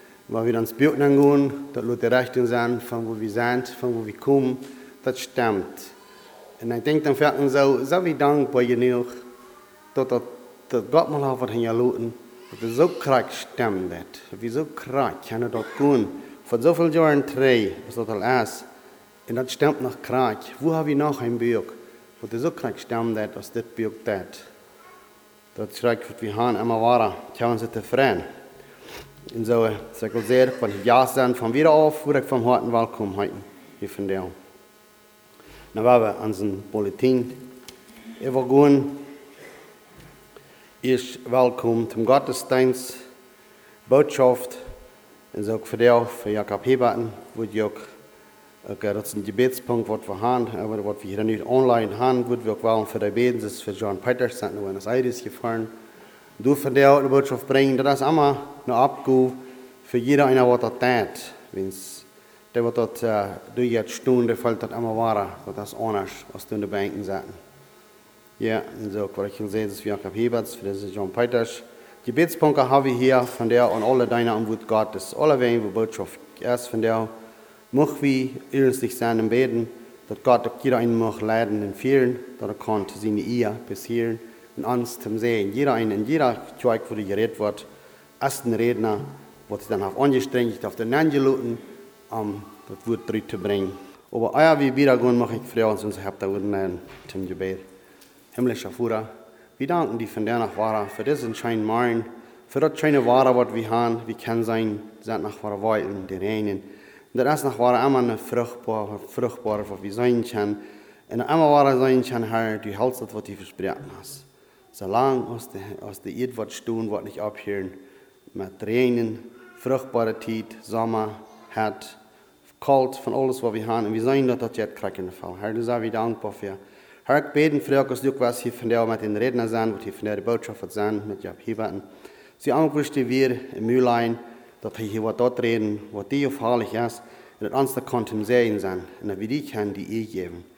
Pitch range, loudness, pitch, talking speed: 110-130 Hz, -23 LUFS, 120 Hz, 165 wpm